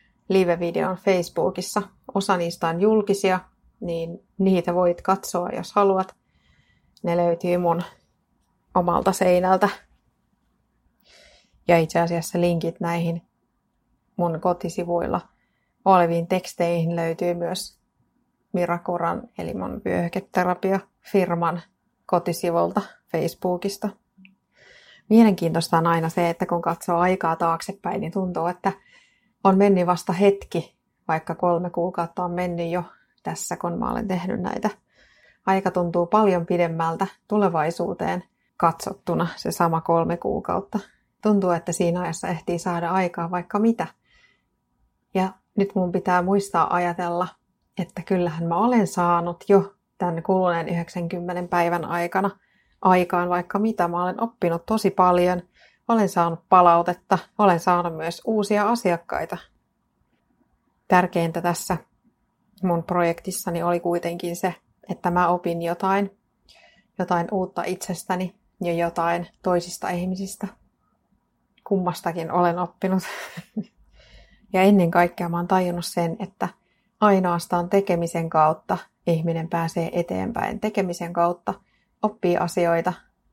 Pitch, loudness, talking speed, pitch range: 180 Hz, -23 LUFS, 110 wpm, 170-190 Hz